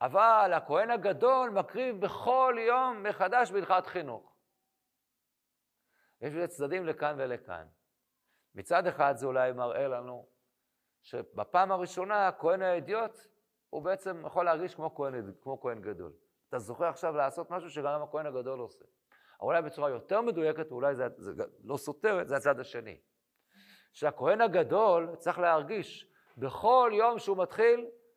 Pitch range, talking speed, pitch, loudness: 140-210 Hz, 130 wpm, 175 Hz, -30 LUFS